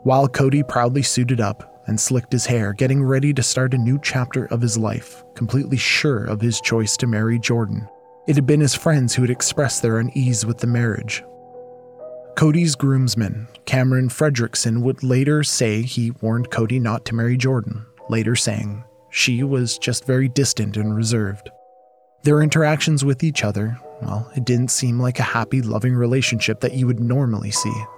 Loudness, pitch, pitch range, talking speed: -19 LUFS, 125 Hz, 115-135 Hz, 175 wpm